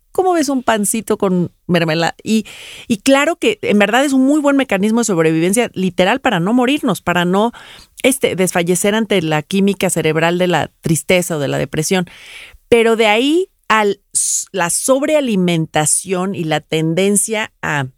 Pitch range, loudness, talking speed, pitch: 175-235 Hz, -15 LUFS, 160 wpm, 195 Hz